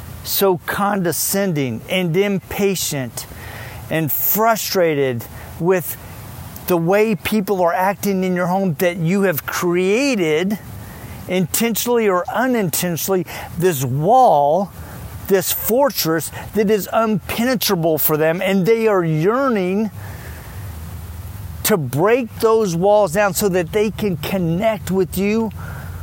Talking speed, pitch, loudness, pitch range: 110 wpm, 185 Hz, -18 LUFS, 155-205 Hz